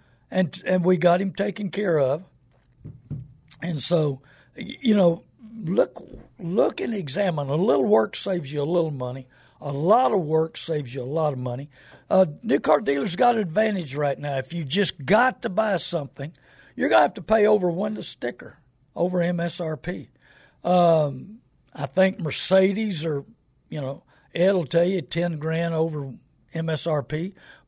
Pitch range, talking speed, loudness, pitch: 140-190 Hz, 165 wpm, -24 LUFS, 165 Hz